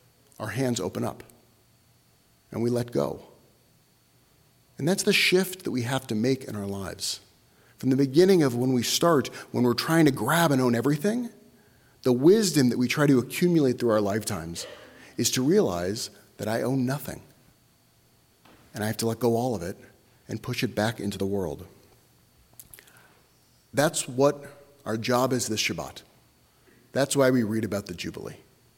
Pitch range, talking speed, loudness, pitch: 110-140 Hz, 170 wpm, -25 LUFS, 125 Hz